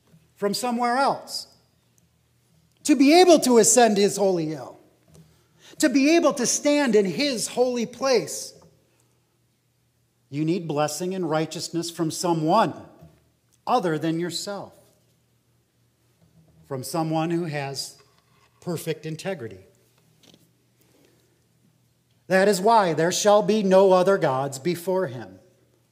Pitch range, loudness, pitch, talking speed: 155-215 Hz, -22 LUFS, 175 Hz, 110 wpm